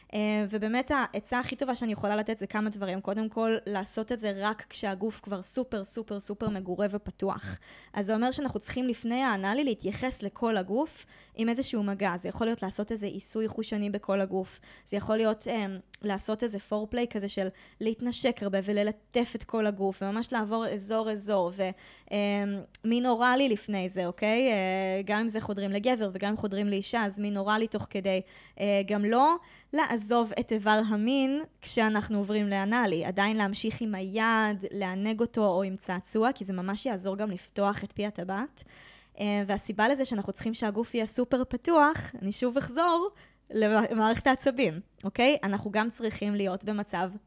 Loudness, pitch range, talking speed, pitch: -30 LUFS, 200-230 Hz, 170 wpm, 215 Hz